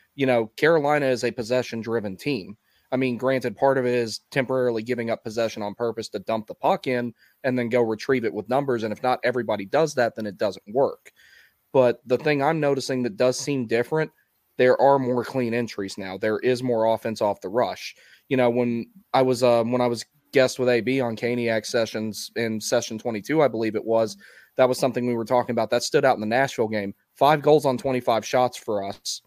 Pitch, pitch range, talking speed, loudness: 120 Hz, 115-130 Hz, 220 wpm, -24 LUFS